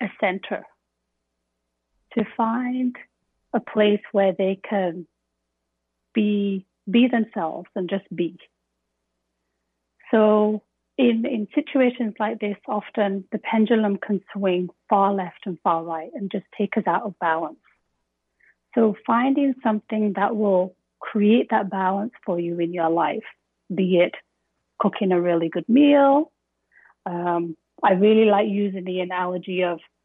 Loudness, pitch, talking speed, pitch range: -22 LUFS, 195 Hz, 130 wpm, 170-215 Hz